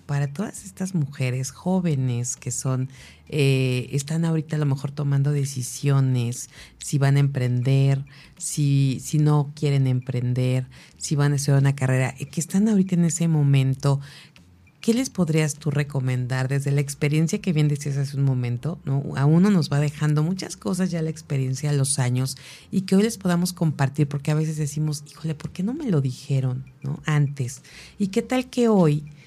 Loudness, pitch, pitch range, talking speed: -23 LUFS, 145 Hz, 135-160 Hz, 180 wpm